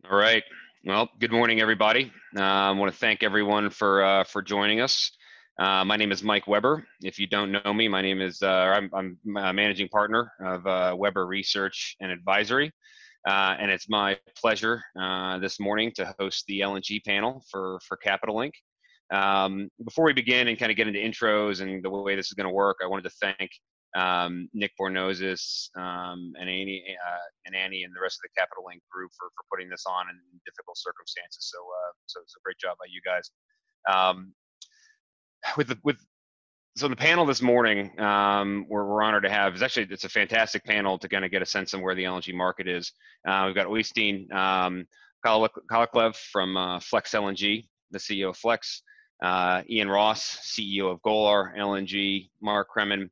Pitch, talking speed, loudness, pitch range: 100 Hz, 195 wpm, -26 LUFS, 95-110 Hz